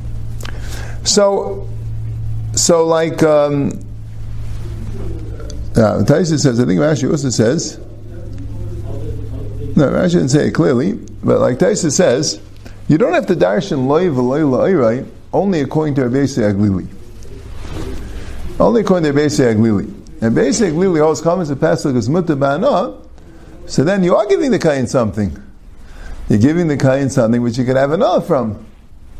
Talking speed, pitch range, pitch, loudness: 140 wpm, 105-150 Hz, 115 Hz, -14 LUFS